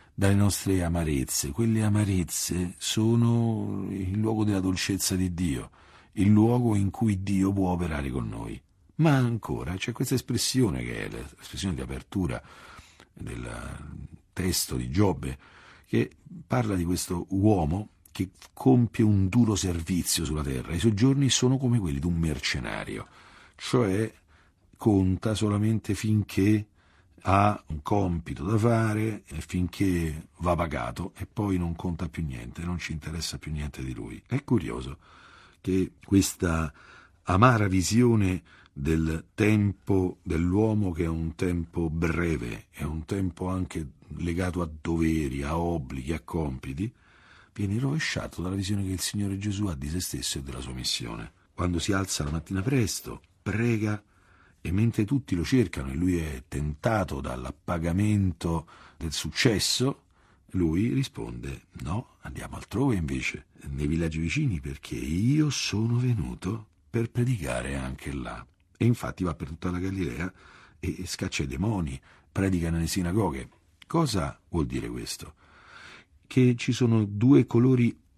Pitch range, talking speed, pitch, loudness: 80-105 Hz, 140 wpm, 90 Hz, -27 LUFS